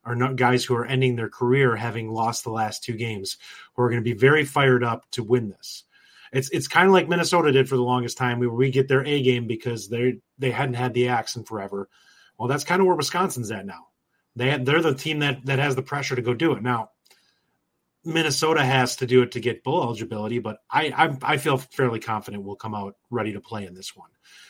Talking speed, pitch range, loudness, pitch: 240 wpm, 115-135 Hz, -23 LUFS, 125 Hz